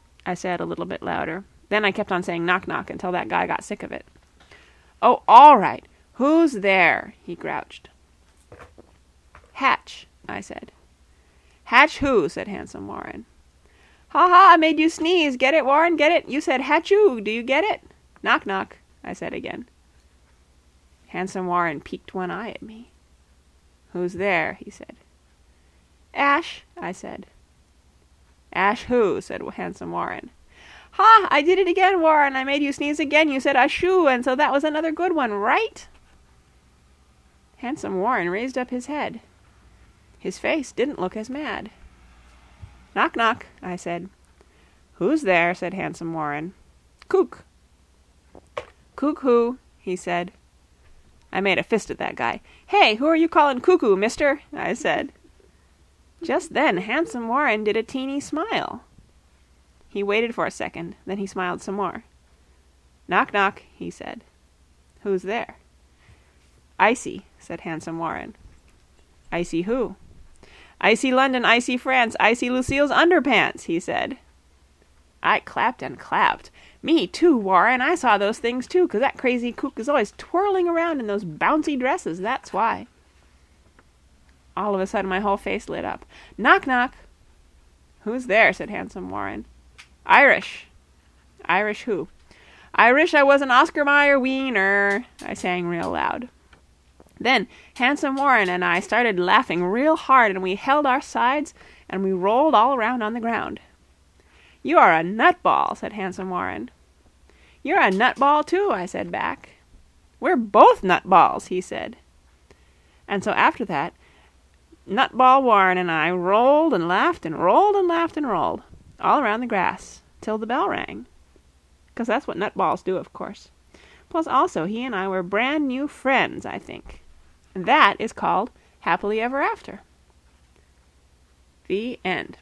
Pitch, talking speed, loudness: 190 Hz, 150 wpm, -20 LUFS